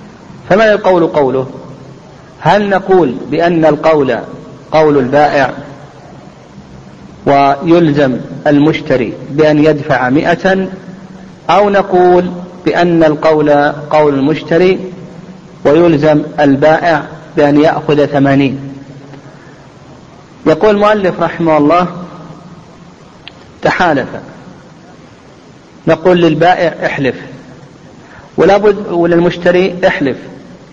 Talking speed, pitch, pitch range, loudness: 70 wpm, 160 Hz, 145-180 Hz, -10 LUFS